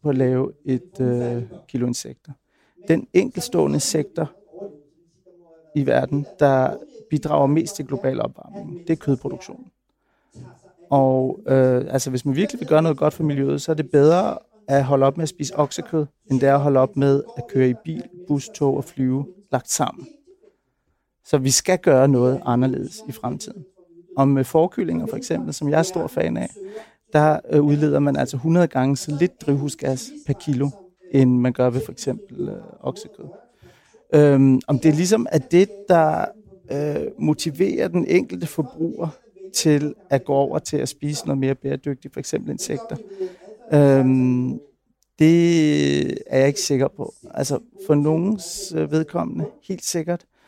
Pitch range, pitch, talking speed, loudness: 135-170 Hz, 150 Hz, 165 wpm, -21 LUFS